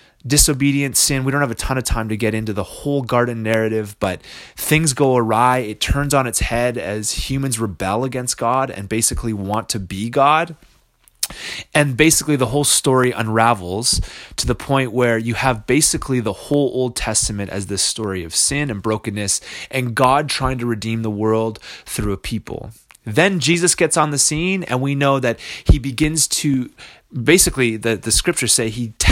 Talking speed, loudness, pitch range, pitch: 185 wpm, -18 LUFS, 110-140 Hz, 125 Hz